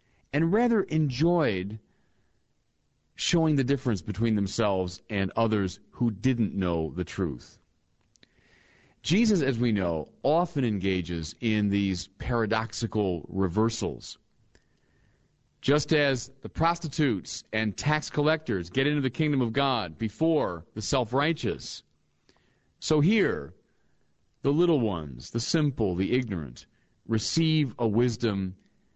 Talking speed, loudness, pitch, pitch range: 110 wpm, -27 LUFS, 115 Hz, 100-145 Hz